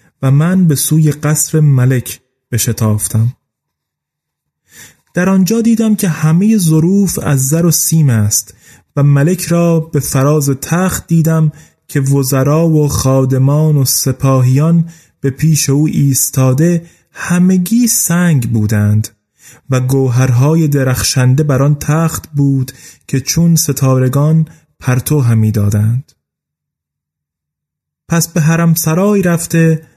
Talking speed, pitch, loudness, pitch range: 110 wpm, 145 Hz, -12 LUFS, 130-165 Hz